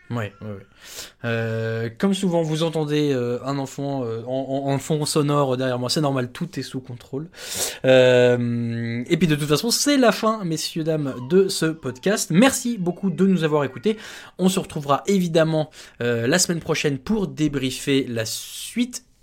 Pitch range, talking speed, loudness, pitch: 125-175 Hz, 175 wpm, -22 LUFS, 150 Hz